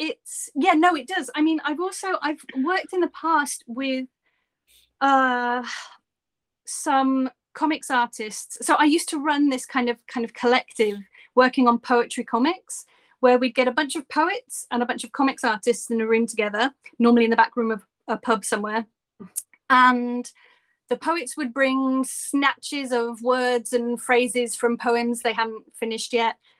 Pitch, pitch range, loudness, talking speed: 255 Hz, 235-300 Hz, -23 LUFS, 170 wpm